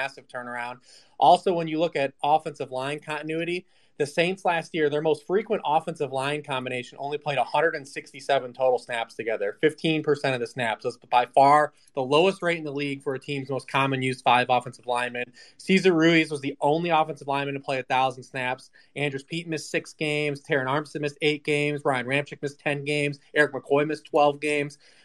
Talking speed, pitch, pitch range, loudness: 190 wpm, 145 Hz, 135-155 Hz, -25 LUFS